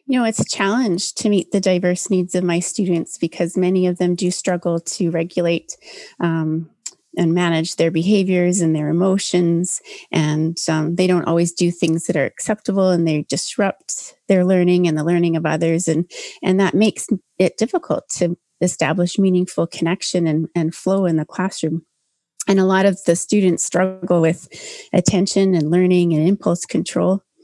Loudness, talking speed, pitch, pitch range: -18 LUFS, 175 wpm, 180 Hz, 165-190 Hz